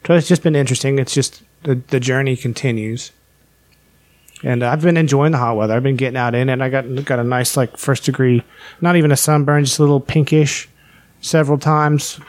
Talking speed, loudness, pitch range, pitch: 205 wpm, -16 LUFS, 125-150 Hz, 135 Hz